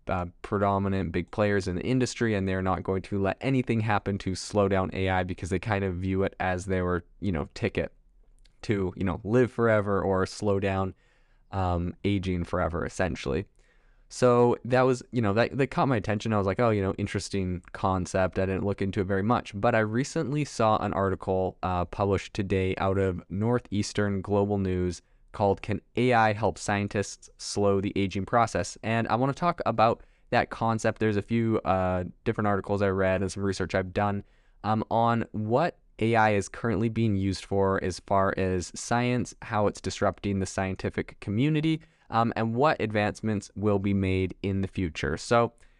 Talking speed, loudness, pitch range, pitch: 185 wpm, -27 LUFS, 95-115 Hz, 100 Hz